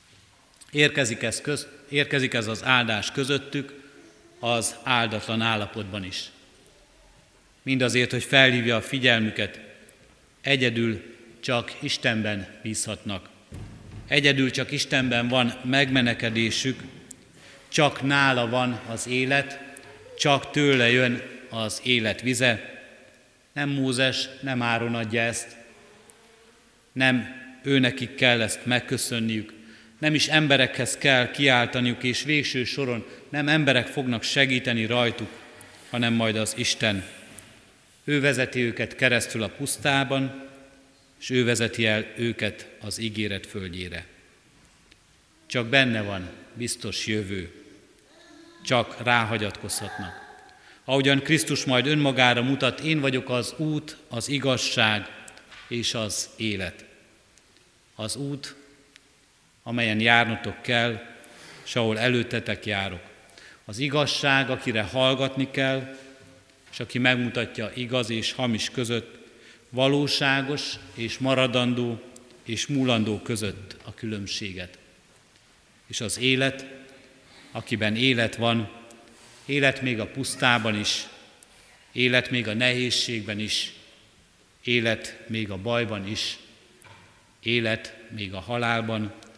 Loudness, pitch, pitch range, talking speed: -24 LUFS, 120 Hz, 110-135 Hz, 105 wpm